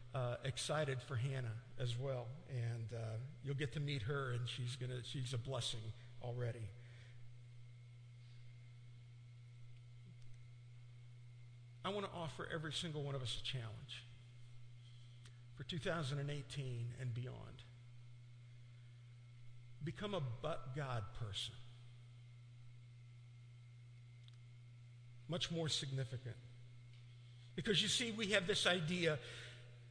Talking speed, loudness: 100 wpm, -43 LUFS